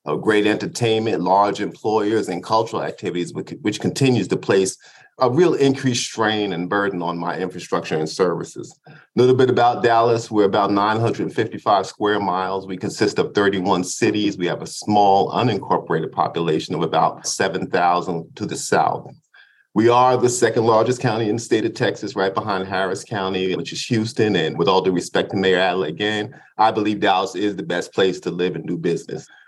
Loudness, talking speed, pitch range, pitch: -20 LUFS, 185 wpm, 95-115 Hz, 105 Hz